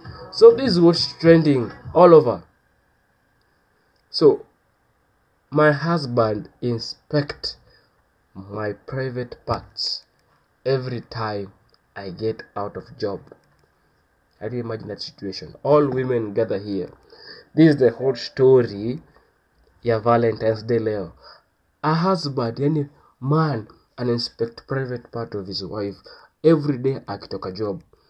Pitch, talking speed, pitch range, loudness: 120 Hz, 115 wpm, 110-145 Hz, -21 LUFS